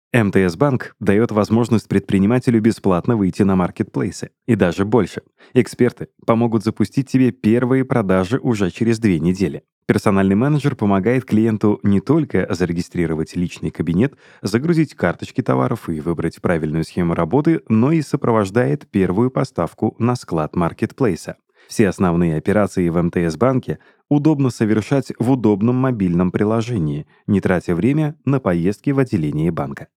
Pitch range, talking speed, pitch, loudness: 95-130 Hz, 130 wpm, 110 Hz, -18 LUFS